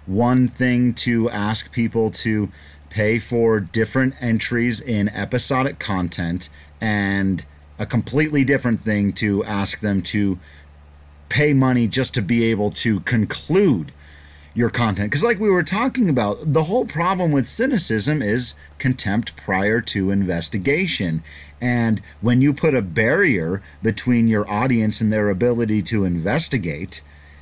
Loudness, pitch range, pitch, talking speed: -20 LUFS, 95-125 Hz, 110 Hz, 135 wpm